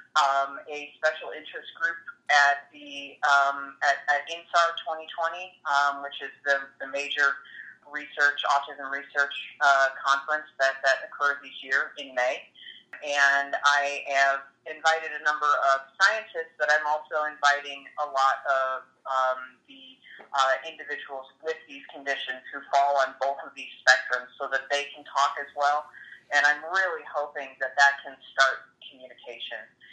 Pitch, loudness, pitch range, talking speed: 140 Hz, -26 LUFS, 135-150 Hz, 150 wpm